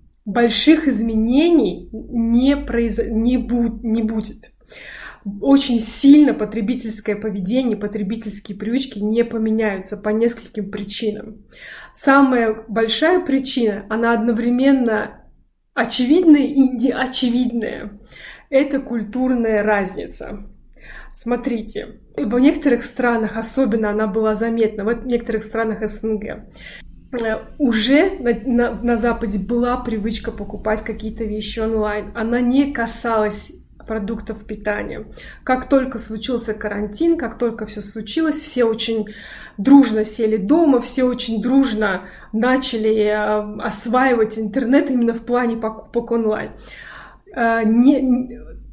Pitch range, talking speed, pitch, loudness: 215-250 Hz, 105 wpm, 230 Hz, -18 LUFS